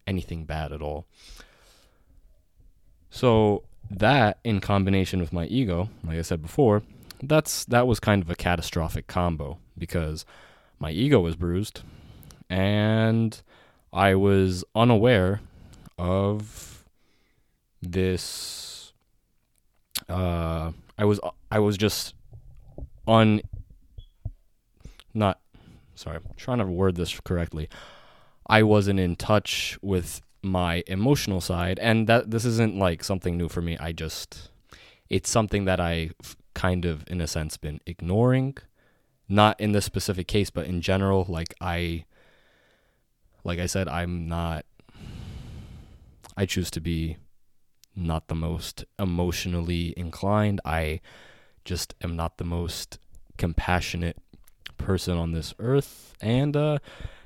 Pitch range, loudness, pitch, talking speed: 85-105 Hz, -26 LUFS, 90 Hz, 120 wpm